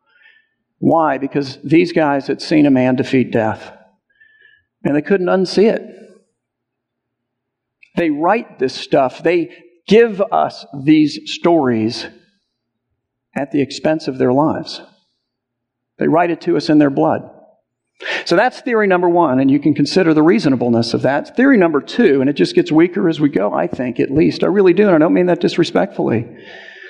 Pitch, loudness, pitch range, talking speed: 160 Hz, -15 LUFS, 135-200 Hz, 170 wpm